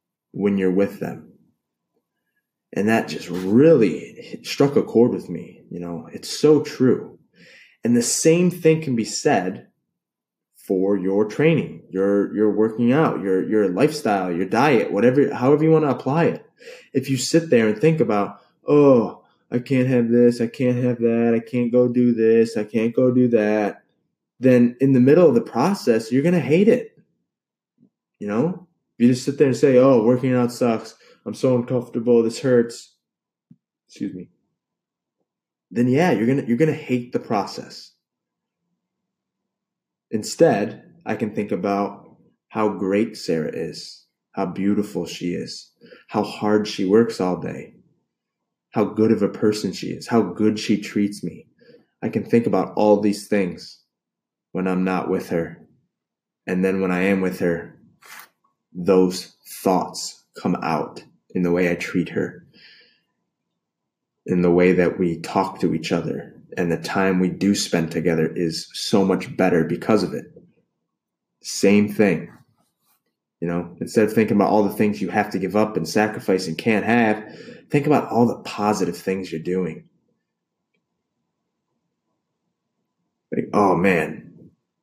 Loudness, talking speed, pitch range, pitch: -20 LUFS, 160 wpm, 95-125 Hz, 110 Hz